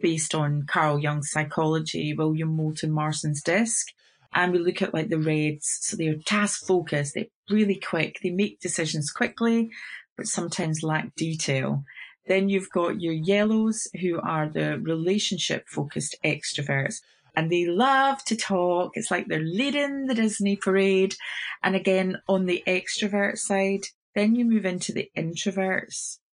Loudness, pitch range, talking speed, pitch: -25 LUFS, 160-200 Hz, 155 wpm, 180 Hz